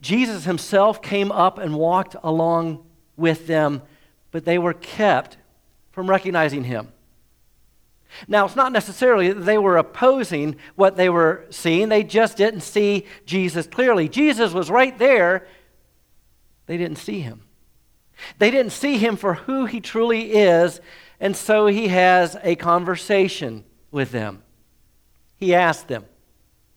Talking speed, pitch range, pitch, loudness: 140 wpm, 155-205 Hz, 180 Hz, -19 LUFS